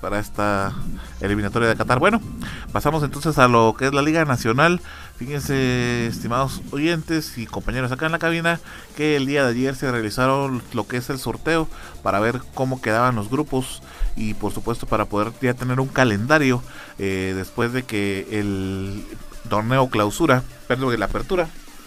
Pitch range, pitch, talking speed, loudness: 105-140 Hz, 125 Hz, 165 wpm, -21 LUFS